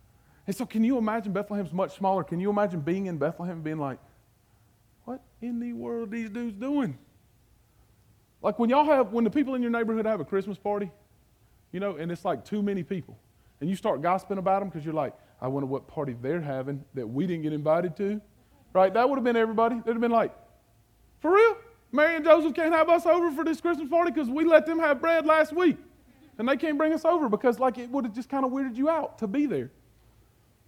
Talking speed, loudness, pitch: 235 wpm, -27 LUFS, 205 Hz